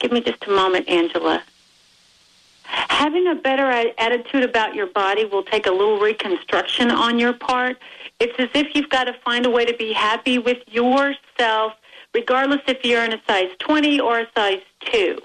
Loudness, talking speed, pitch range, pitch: -19 LUFS, 180 wpm, 220-280 Hz, 245 Hz